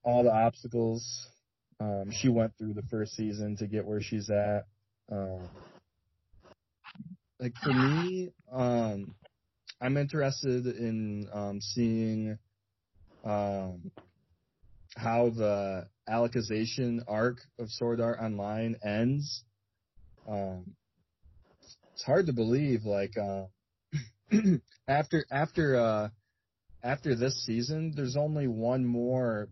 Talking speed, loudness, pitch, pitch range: 105 wpm, -31 LUFS, 115 Hz, 105-125 Hz